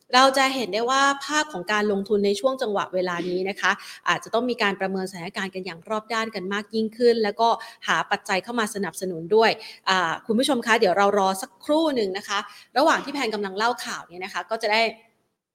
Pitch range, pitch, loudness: 190-235 Hz, 210 Hz, -23 LUFS